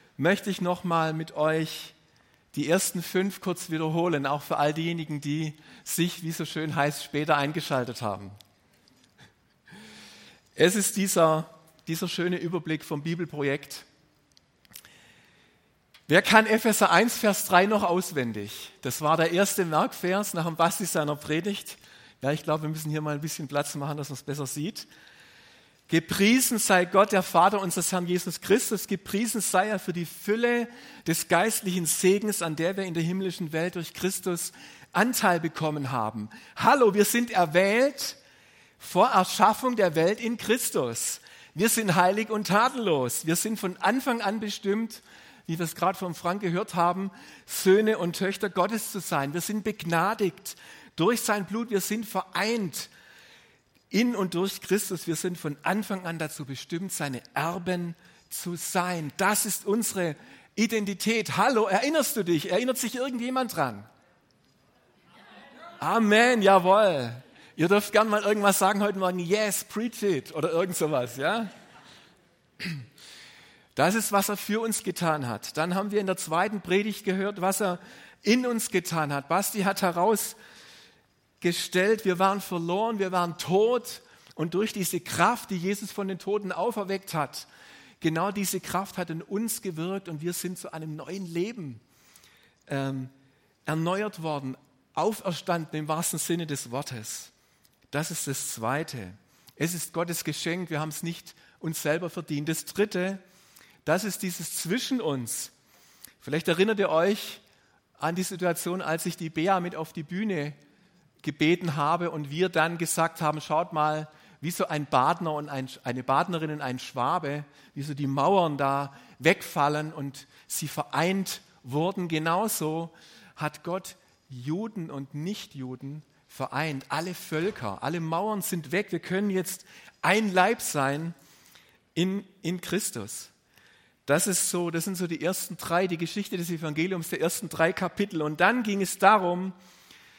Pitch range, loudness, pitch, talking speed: 155-195 Hz, -27 LUFS, 175 Hz, 155 wpm